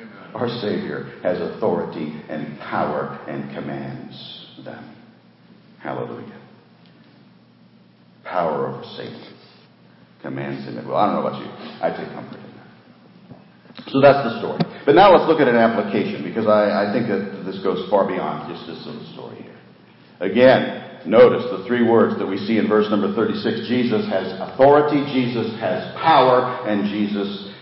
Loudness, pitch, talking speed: -19 LUFS, 105 Hz, 155 wpm